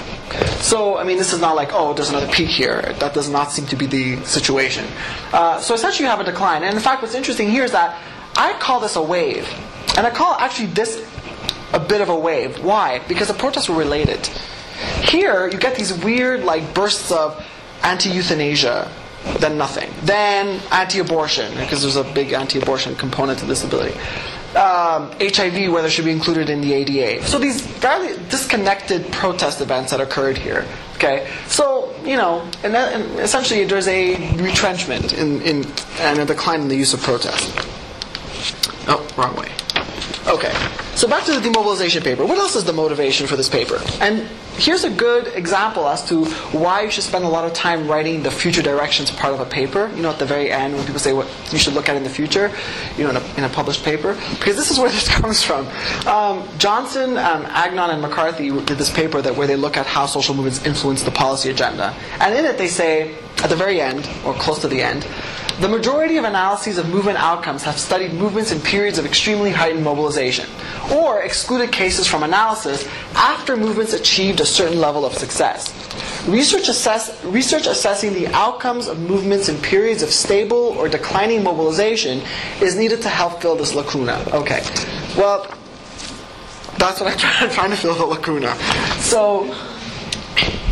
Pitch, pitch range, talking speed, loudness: 175 Hz, 145-215 Hz, 190 wpm, -18 LUFS